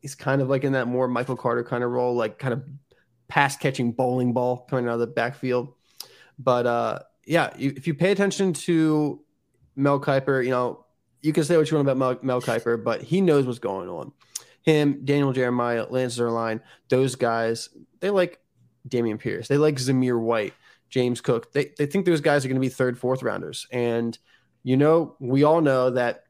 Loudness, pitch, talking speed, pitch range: -24 LUFS, 130 Hz, 205 wpm, 120-145 Hz